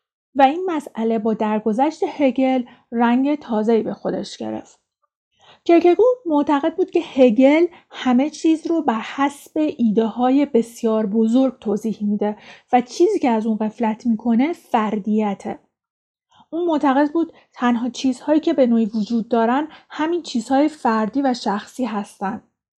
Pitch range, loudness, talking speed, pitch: 225-295 Hz, -19 LUFS, 135 wpm, 255 Hz